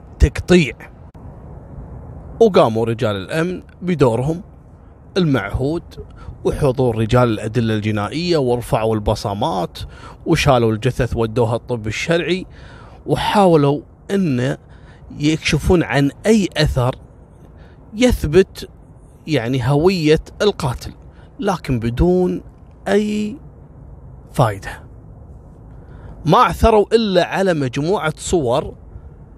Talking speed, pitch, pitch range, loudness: 75 wpm, 140 Hz, 120-180 Hz, -17 LUFS